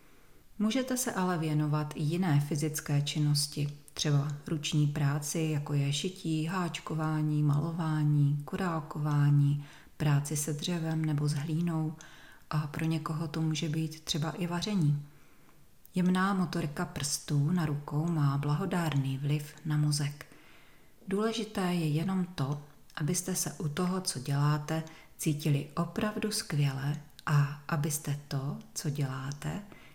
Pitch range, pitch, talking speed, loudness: 145-170 Hz, 155 Hz, 120 wpm, -32 LUFS